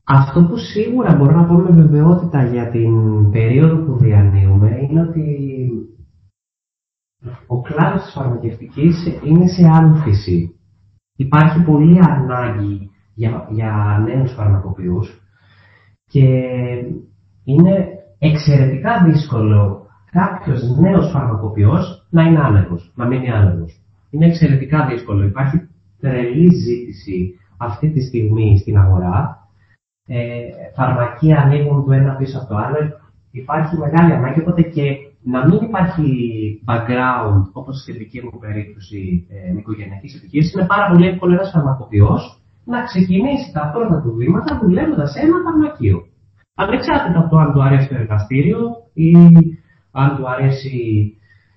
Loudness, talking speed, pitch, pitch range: -14 LUFS, 120 wpm, 130 Hz, 105-160 Hz